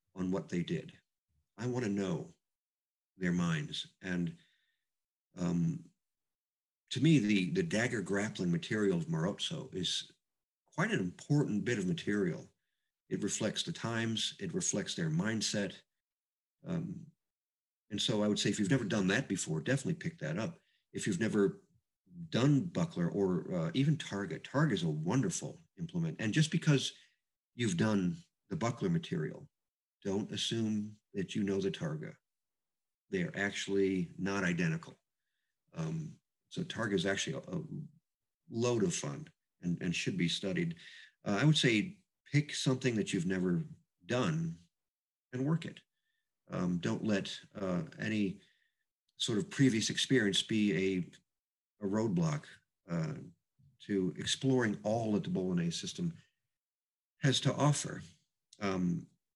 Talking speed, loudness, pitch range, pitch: 140 wpm, -34 LUFS, 100-170 Hz, 135 Hz